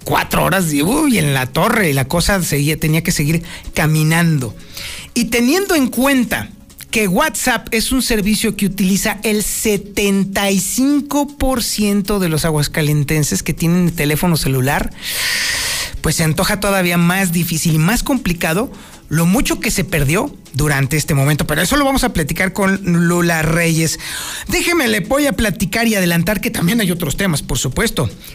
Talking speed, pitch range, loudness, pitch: 160 wpm, 160-230 Hz, -15 LUFS, 190 Hz